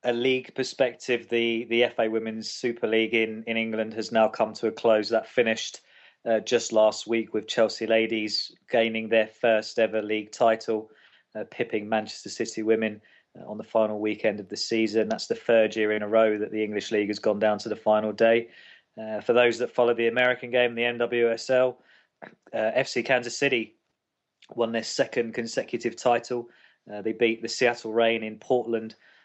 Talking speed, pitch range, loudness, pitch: 185 wpm, 110-120 Hz, -25 LUFS, 115 Hz